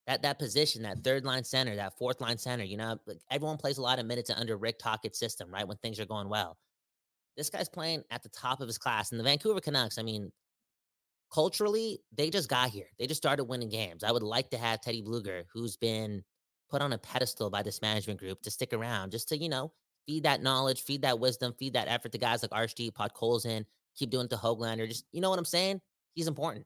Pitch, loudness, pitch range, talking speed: 120 Hz, -33 LUFS, 110-140 Hz, 240 wpm